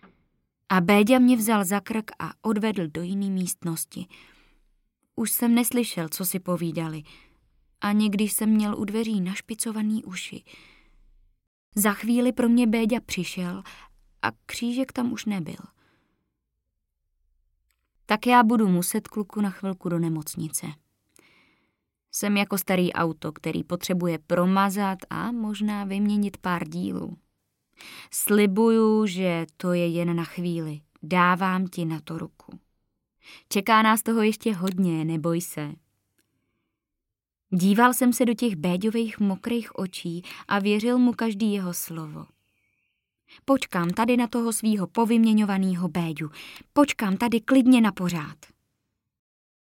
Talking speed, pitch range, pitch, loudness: 125 wpm, 170-225 Hz, 195 Hz, -24 LUFS